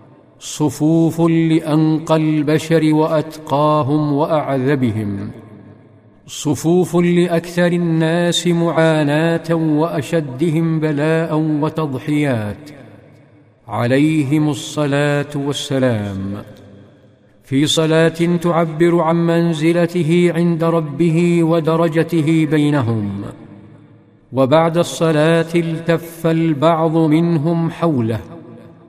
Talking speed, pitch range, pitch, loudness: 60 wpm, 140-165 Hz, 155 Hz, -16 LUFS